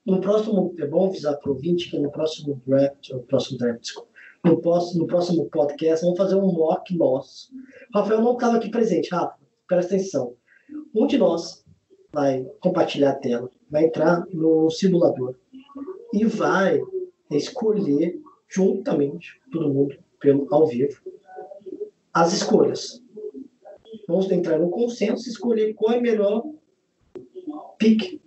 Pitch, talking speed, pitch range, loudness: 190 Hz, 140 wpm, 155-245 Hz, -22 LUFS